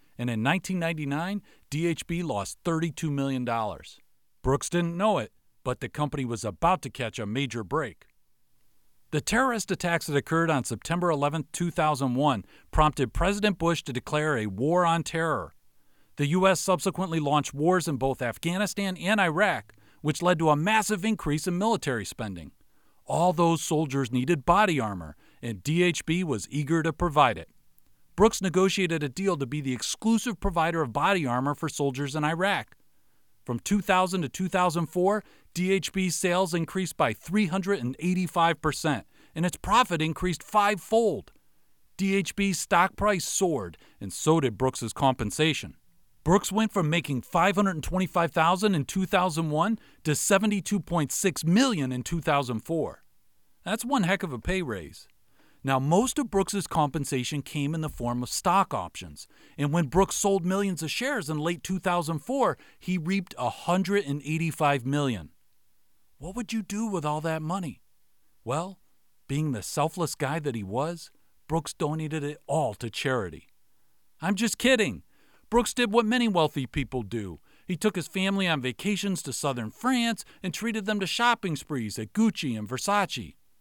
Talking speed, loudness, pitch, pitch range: 150 wpm, -27 LUFS, 165 Hz, 140-190 Hz